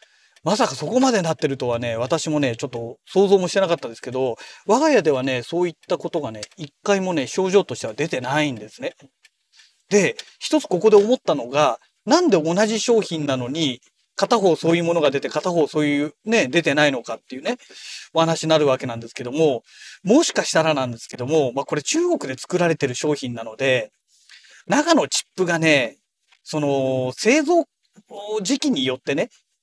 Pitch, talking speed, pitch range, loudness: 160 Hz, 360 characters per minute, 135-200 Hz, -20 LUFS